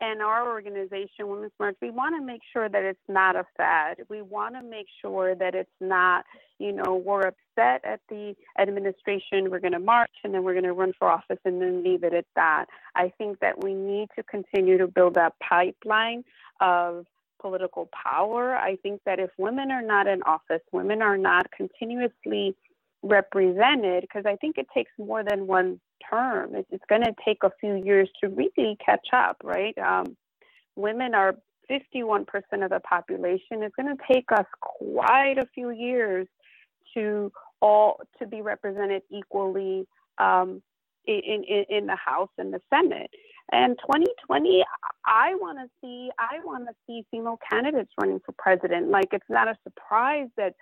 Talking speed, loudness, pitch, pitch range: 175 wpm, -25 LUFS, 205 Hz, 190-235 Hz